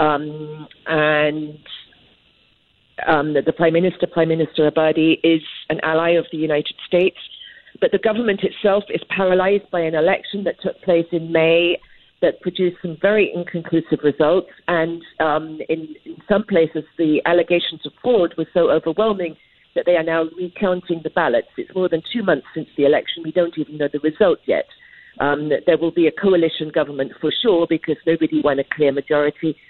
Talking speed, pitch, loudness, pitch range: 175 wpm, 165 Hz, -19 LUFS, 155-175 Hz